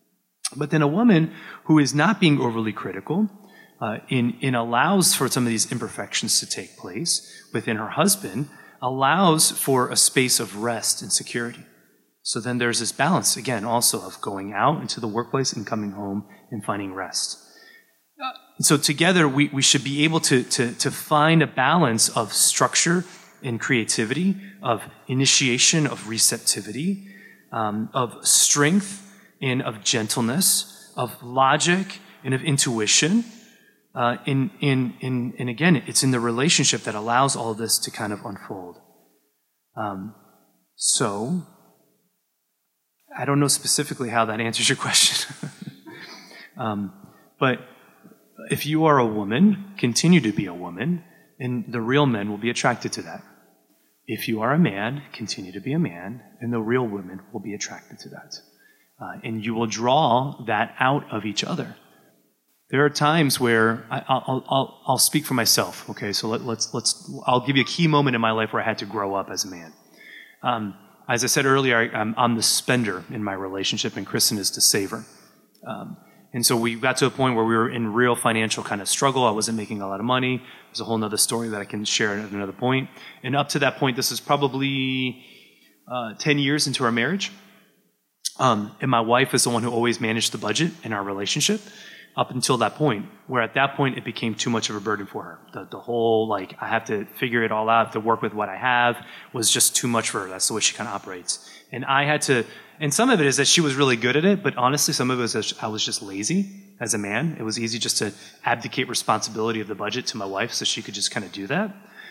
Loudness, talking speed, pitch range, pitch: -22 LUFS, 205 wpm, 110-145 Hz, 125 Hz